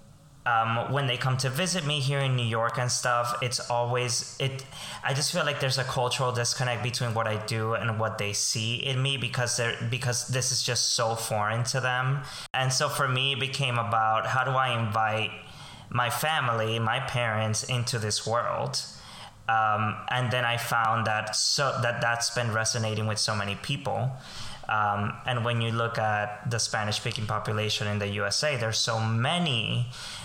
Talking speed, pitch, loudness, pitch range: 185 wpm, 120 Hz, -27 LUFS, 110-130 Hz